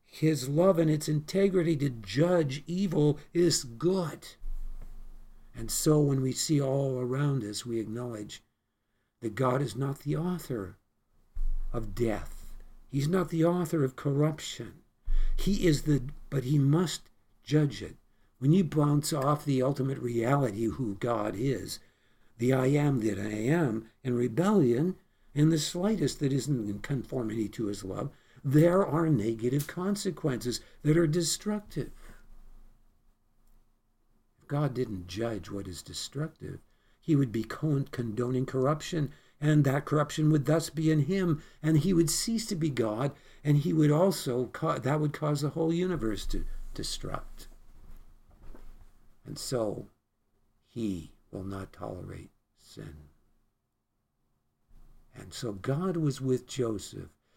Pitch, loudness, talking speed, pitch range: 135 Hz, -29 LUFS, 135 wpm, 115-155 Hz